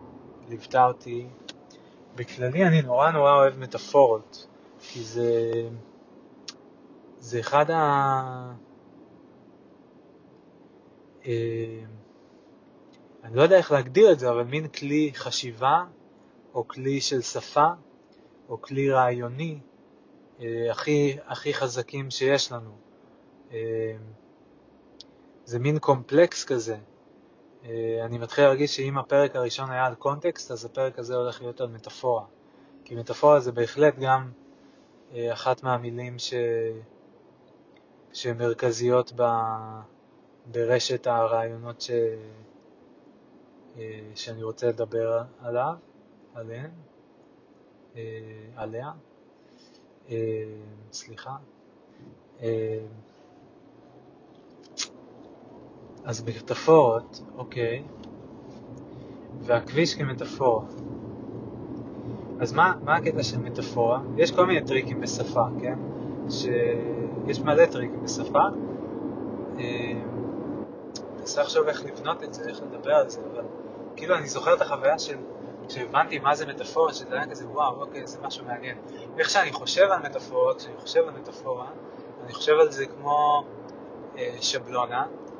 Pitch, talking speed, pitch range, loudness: 125 Hz, 105 wpm, 115-140 Hz, -25 LUFS